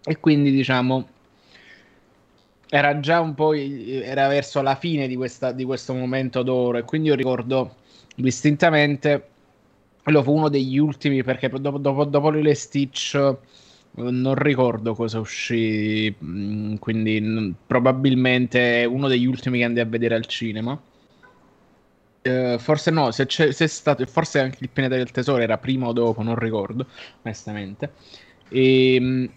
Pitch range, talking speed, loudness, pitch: 120-140 Hz, 145 wpm, -21 LUFS, 130 Hz